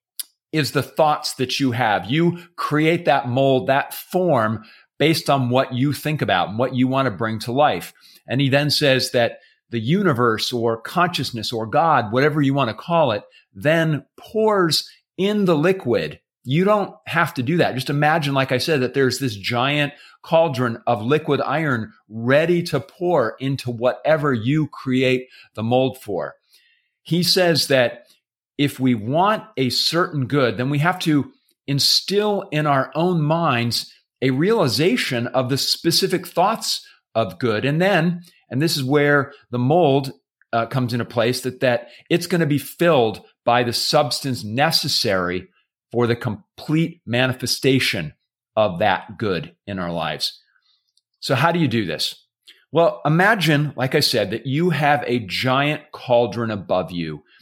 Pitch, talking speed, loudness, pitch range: 135 Hz, 160 wpm, -20 LUFS, 120-155 Hz